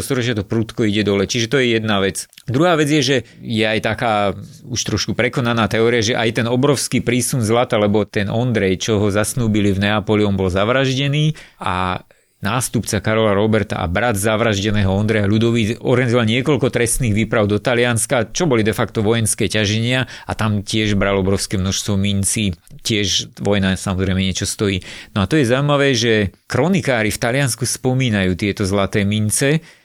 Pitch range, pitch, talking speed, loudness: 100-125 Hz, 110 Hz, 170 wpm, -17 LUFS